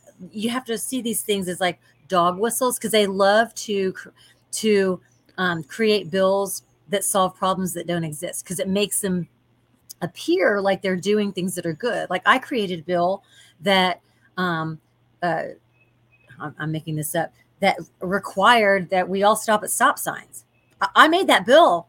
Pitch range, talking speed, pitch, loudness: 165-205 Hz, 165 wpm, 185 Hz, -21 LUFS